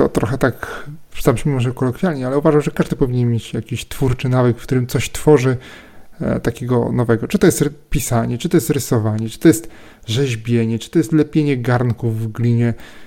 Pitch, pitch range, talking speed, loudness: 130 Hz, 115-150 Hz, 190 wpm, -18 LUFS